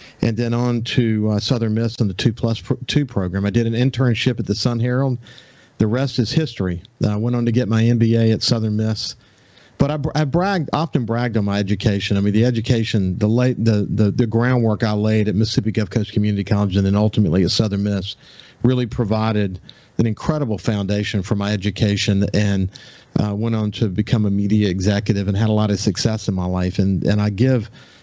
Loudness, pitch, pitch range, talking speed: -19 LUFS, 110 Hz, 105-120 Hz, 210 wpm